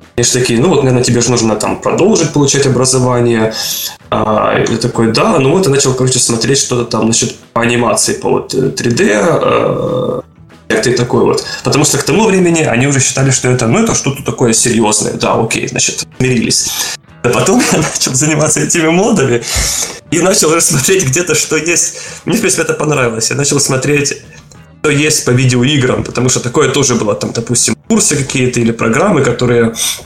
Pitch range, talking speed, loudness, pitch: 120-145 Hz, 185 wpm, -11 LUFS, 130 Hz